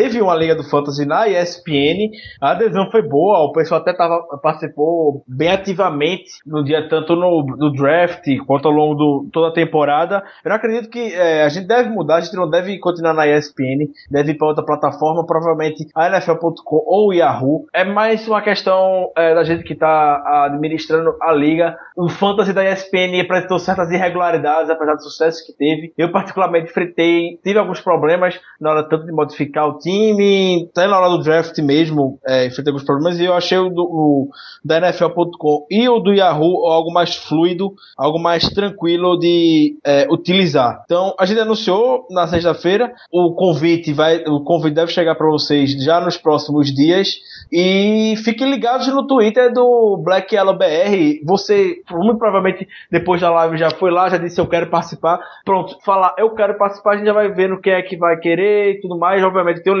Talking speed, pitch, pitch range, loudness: 190 wpm, 170 Hz, 155-190 Hz, -15 LUFS